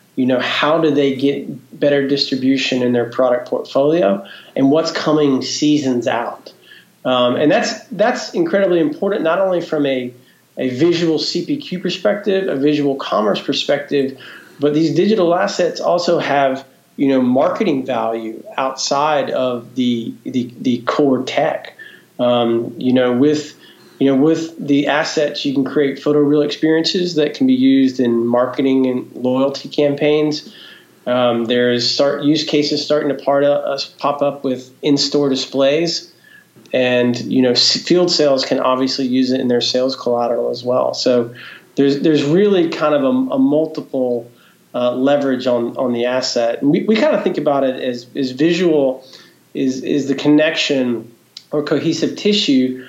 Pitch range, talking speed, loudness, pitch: 125-155 Hz, 160 wpm, -16 LUFS, 140 Hz